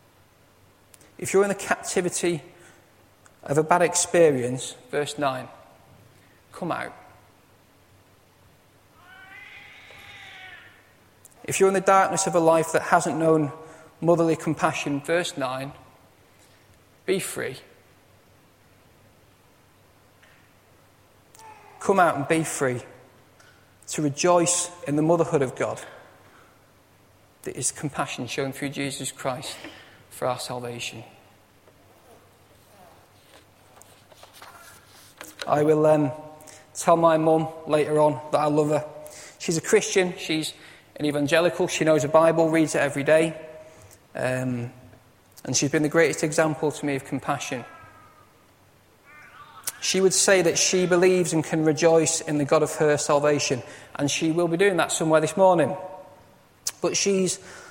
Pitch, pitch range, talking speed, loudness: 155 Hz, 130-170 Hz, 120 wpm, -23 LUFS